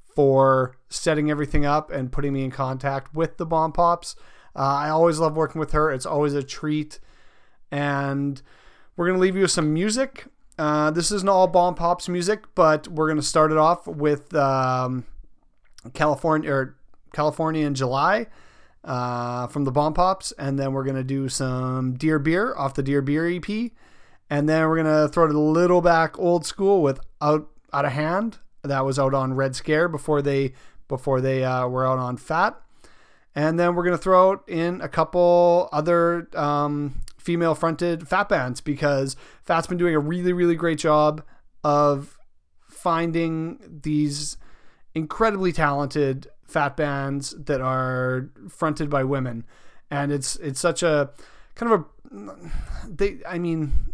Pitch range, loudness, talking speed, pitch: 140-170 Hz, -23 LUFS, 165 wpm, 150 Hz